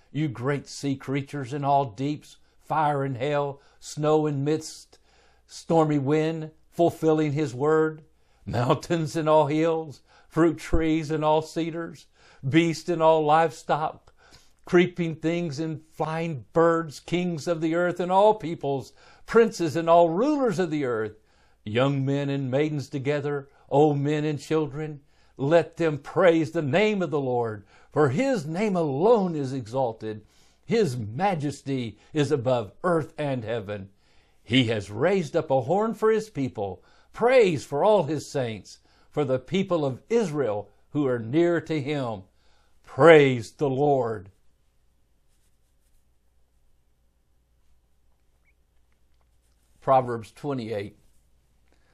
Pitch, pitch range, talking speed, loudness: 145 Hz, 115-160 Hz, 125 wpm, -25 LUFS